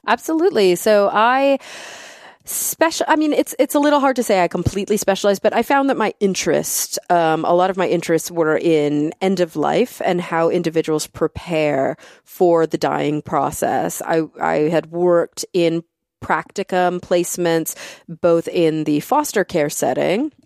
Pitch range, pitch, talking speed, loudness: 165-230 Hz, 180 Hz, 160 wpm, -18 LUFS